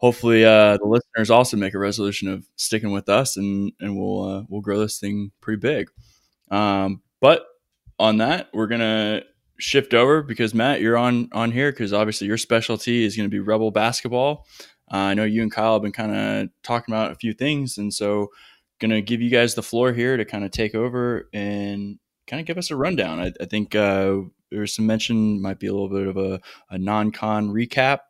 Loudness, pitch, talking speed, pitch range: -21 LUFS, 110 Hz, 210 wpm, 100-115 Hz